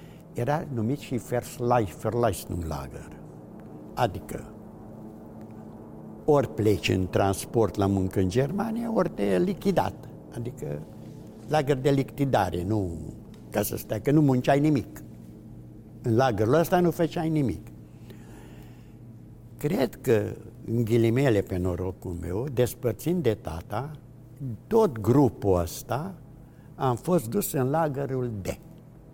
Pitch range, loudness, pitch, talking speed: 105-145 Hz, -26 LUFS, 120 Hz, 115 wpm